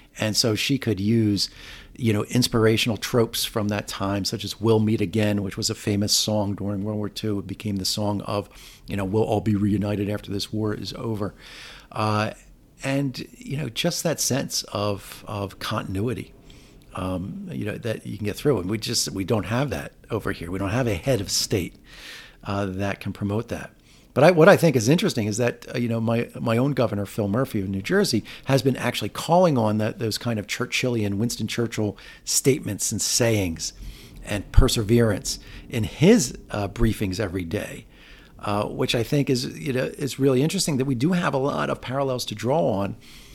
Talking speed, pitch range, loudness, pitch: 200 wpm, 100-125 Hz, -24 LUFS, 110 Hz